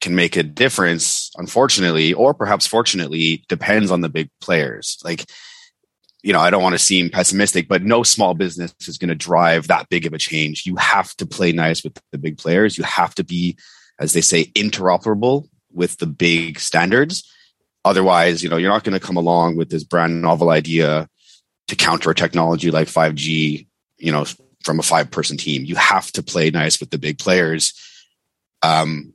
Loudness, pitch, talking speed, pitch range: -17 LUFS, 85 Hz, 190 wpm, 80-95 Hz